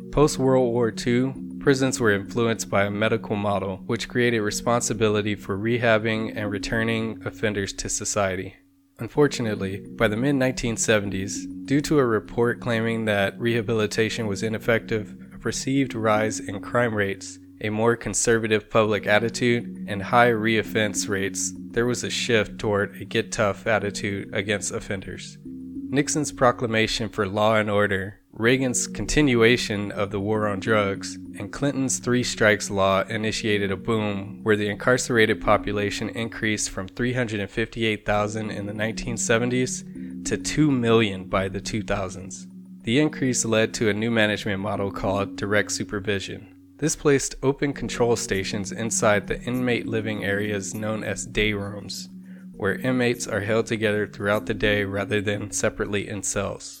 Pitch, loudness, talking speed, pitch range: 105 Hz, -24 LUFS, 140 wpm, 100-115 Hz